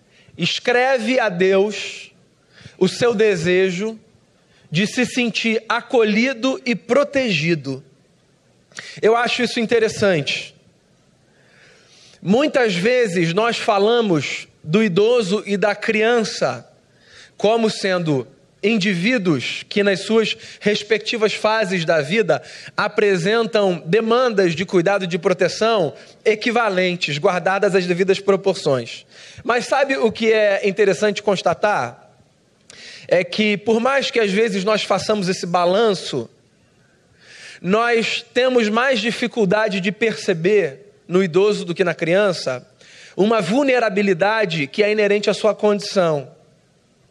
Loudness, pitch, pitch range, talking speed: -18 LUFS, 210 Hz, 185-225 Hz, 110 wpm